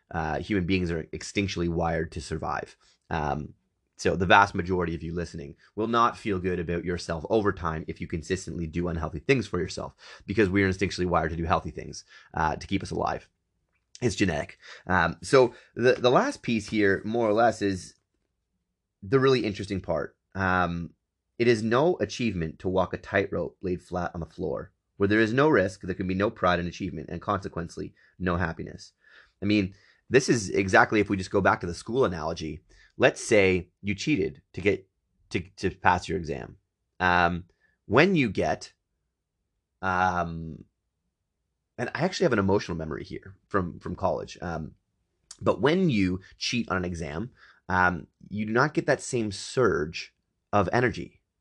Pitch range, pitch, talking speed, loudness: 85-100 Hz, 90 Hz, 175 wpm, -27 LUFS